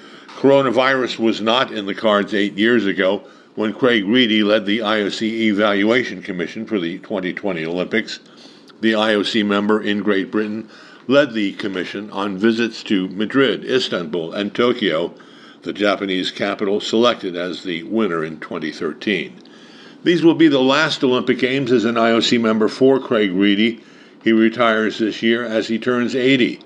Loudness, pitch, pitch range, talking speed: -18 LUFS, 110 Hz, 105-125 Hz, 155 wpm